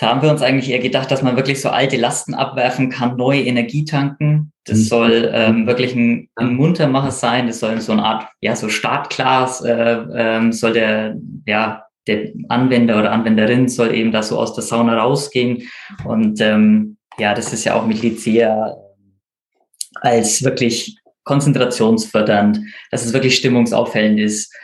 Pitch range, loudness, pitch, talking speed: 110-130 Hz, -16 LUFS, 120 Hz, 170 wpm